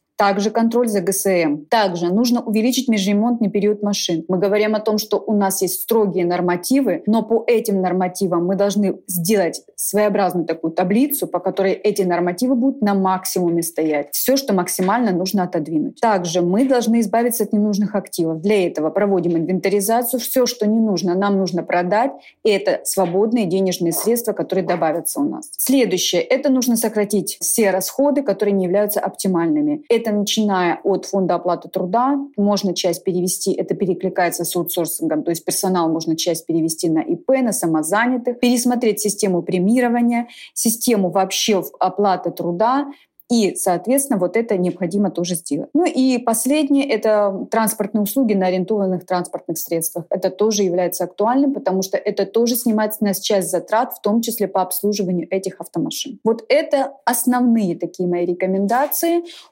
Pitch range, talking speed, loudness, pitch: 180-230 Hz, 155 wpm, -18 LUFS, 200 Hz